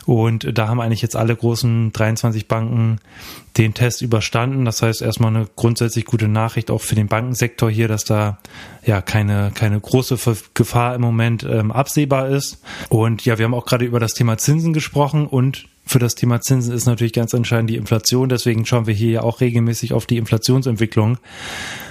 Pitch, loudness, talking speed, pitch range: 115 Hz, -18 LUFS, 185 wpm, 110-125 Hz